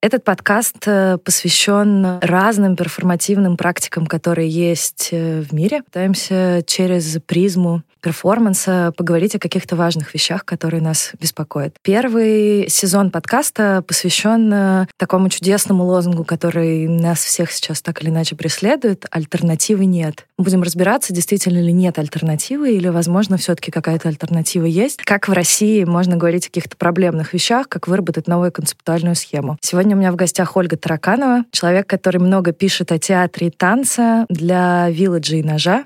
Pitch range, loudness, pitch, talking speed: 170-195 Hz, -16 LUFS, 180 Hz, 140 wpm